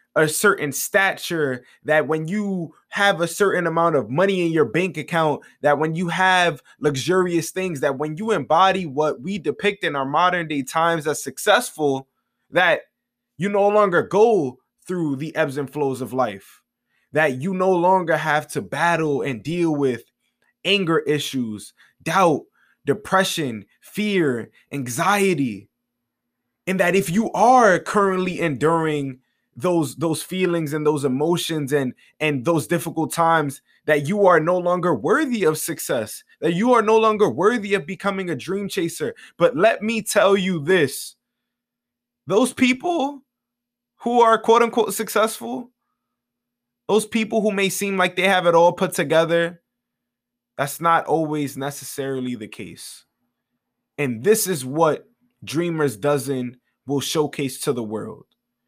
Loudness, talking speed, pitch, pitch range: -20 LUFS, 145 wpm, 165 Hz, 145-195 Hz